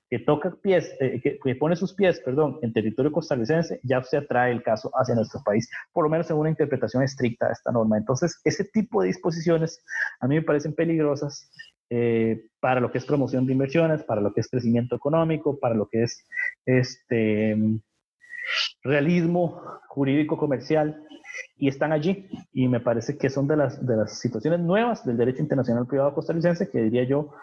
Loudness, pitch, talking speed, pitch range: -24 LUFS, 140 Hz, 185 wpm, 120-165 Hz